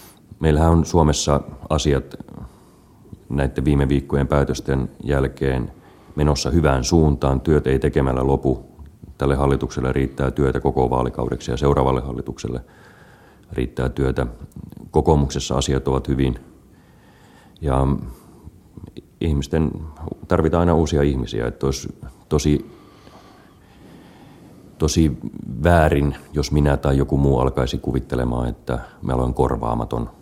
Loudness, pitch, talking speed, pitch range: -20 LUFS, 70 Hz, 105 wpm, 65-75 Hz